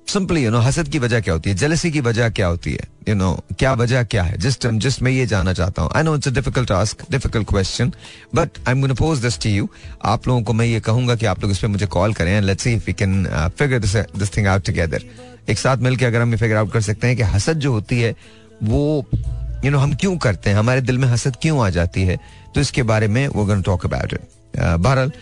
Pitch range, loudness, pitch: 105-130 Hz, -19 LUFS, 115 Hz